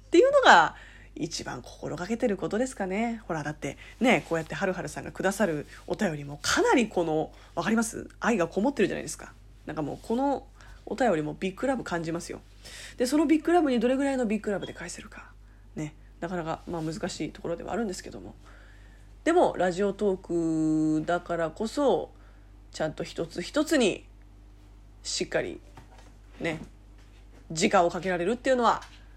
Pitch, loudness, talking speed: 170 Hz, -27 LUFS, 370 characters per minute